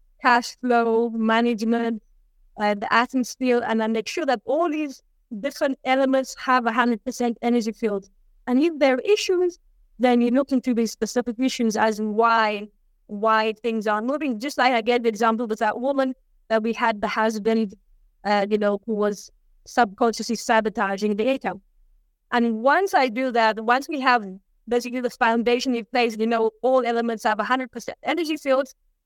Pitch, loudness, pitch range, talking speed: 235 Hz, -22 LUFS, 220-255 Hz, 175 wpm